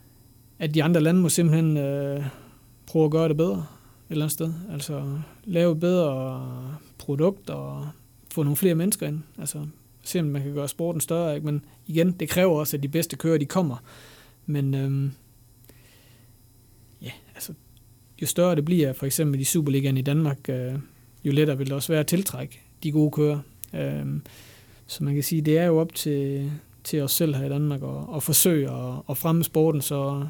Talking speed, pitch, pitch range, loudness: 185 wpm, 145 Hz, 125-160 Hz, -25 LUFS